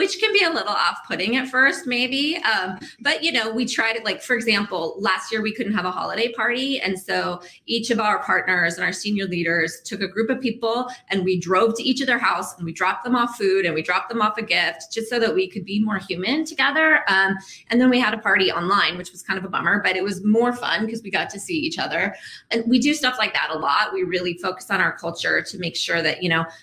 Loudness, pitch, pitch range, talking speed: -21 LUFS, 215 Hz, 185-250 Hz, 265 wpm